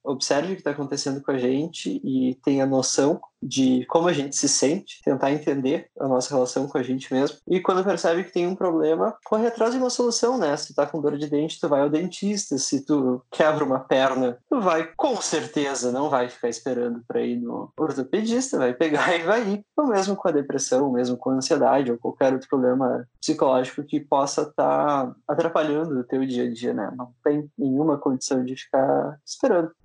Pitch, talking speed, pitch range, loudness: 140 Hz, 210 wpm, 130-165 Hz, -23 LUFS